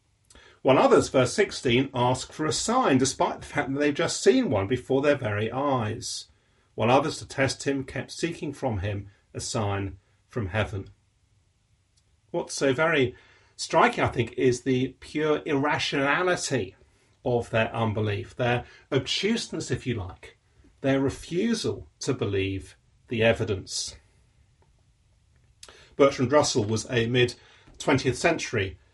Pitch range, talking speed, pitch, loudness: 105-135 Hz, 135 wpm, 125 Hz, -26 LUFS